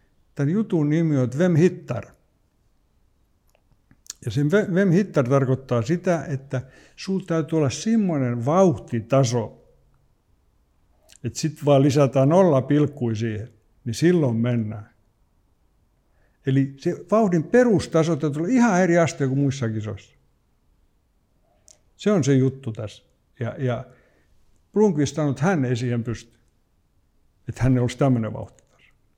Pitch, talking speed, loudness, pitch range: 135 Hz, 120 wpm, -22 LUFS, 115-165 Hz